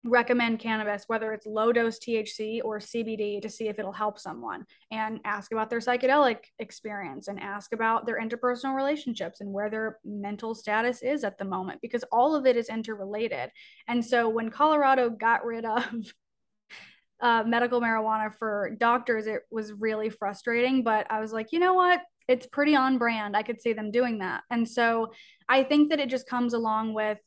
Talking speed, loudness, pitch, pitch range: 185 wpm, -27 LUFS, 230 Hz, 215-245 Hz